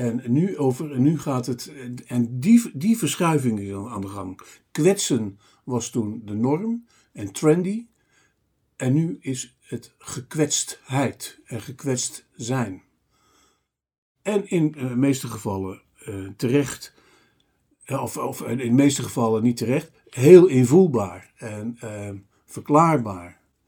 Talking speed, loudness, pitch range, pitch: 130 wpm, -22 LUFS, 110-150 Hz, 125 Hz